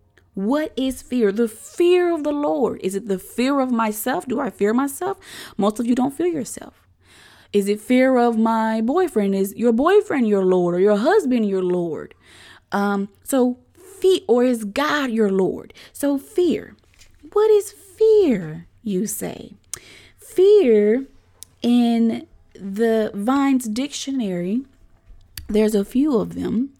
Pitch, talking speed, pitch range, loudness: 235 Hz, 145 wpm, 205-280 Hz, -20 LUFS